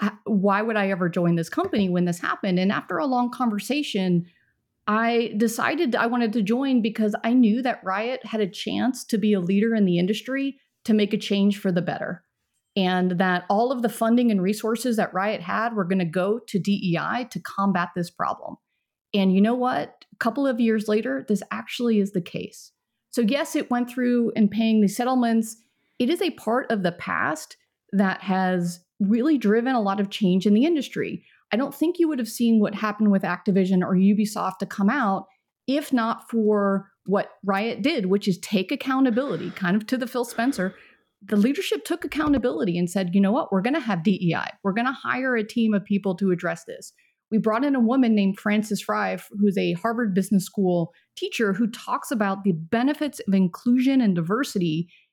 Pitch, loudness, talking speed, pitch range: 215 Hz, -23 LUFS, 200 wpm, 195-245 Hz